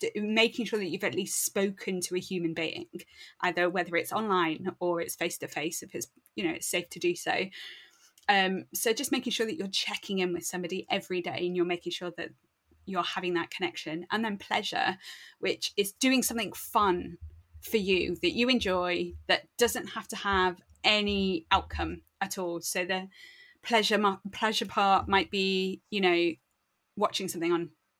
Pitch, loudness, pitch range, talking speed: 190 Hz, -29 LUFS, 175-215 Hz, 180 wpm